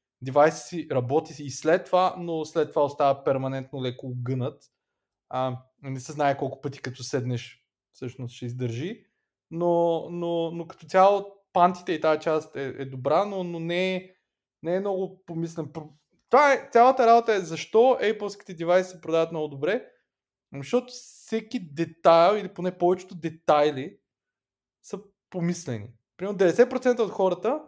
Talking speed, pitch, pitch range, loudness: 150 wpm, 165 Hz, 140-185 Hz, -25 LUFS